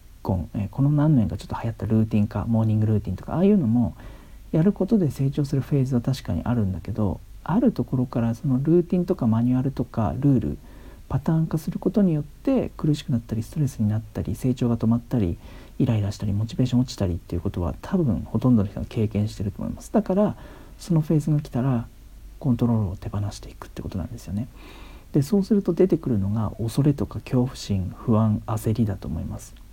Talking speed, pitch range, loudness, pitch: 470 characters per minute, 105-140 Hz, -24 LUFS, 115 Hz